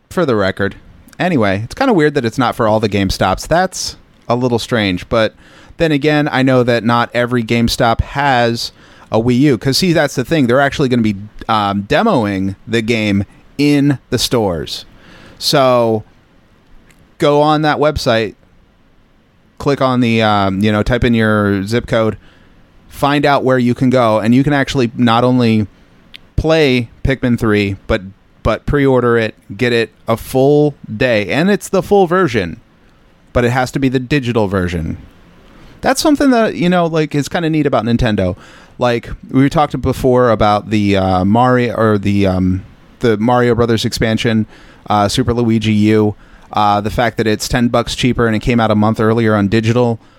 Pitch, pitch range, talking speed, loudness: 120 Hz, 105-130 Hz, 180 wpm, -14 LUFS